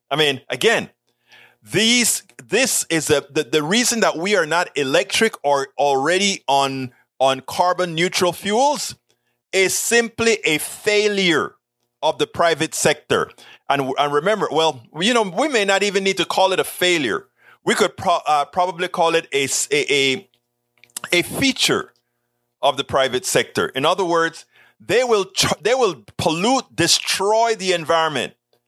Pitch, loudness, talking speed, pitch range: 170 Hz, -18 LUFS, 155 wpm, 140-205 Hz